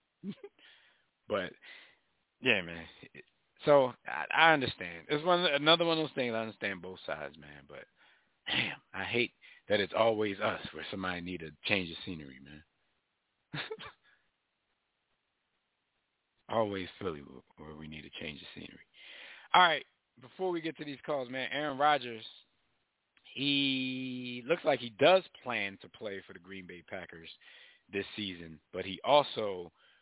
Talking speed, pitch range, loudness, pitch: 145 wpm, 90-145 Hz, -32 LUFS, 110 Hz